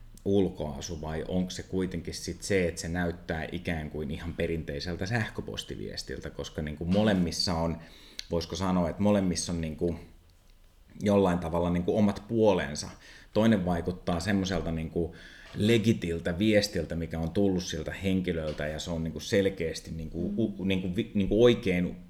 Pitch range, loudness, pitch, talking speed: 80-95 Hz, -29 LUFS, 90 Hz, 155 wpm